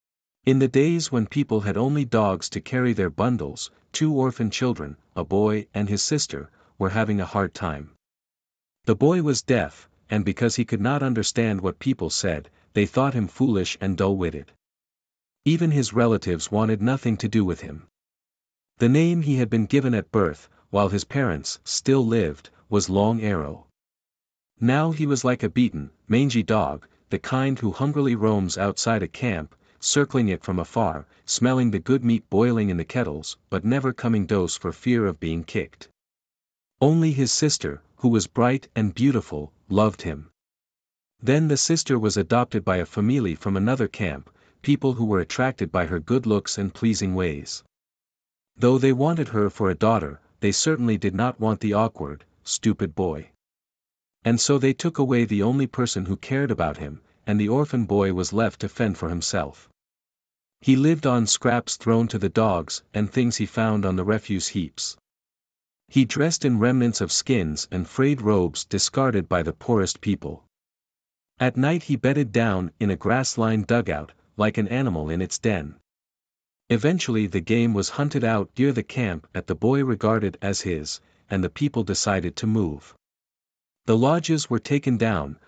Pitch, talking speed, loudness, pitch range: 110 Hz, 175 wpm, -23 LUFS, 95-125 Hz